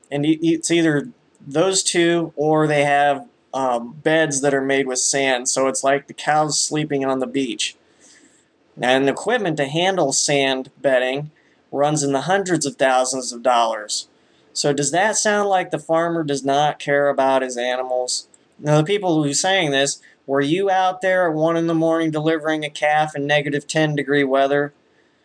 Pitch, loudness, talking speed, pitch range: 145 Hz, -19 LUFS, 185 wpm, 135-165 Hz